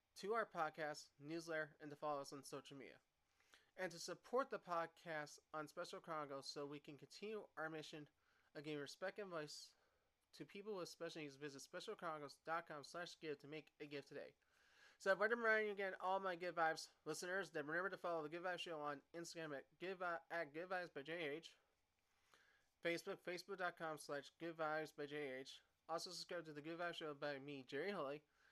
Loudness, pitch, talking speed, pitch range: -49 LUFS, 160 Hz, 185 wpm, 150-180 Hz